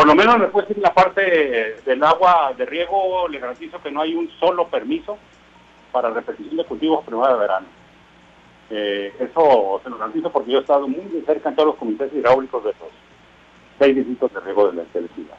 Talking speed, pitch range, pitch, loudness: 200 wpm, 125-185 Hz, 155 Hz, -19 LUFS